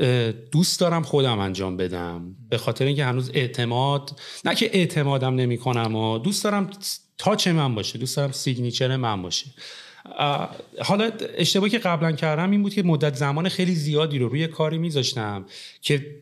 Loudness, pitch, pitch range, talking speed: -23 LUFS, 140 Hz, 120-170 Hz, 160 wpm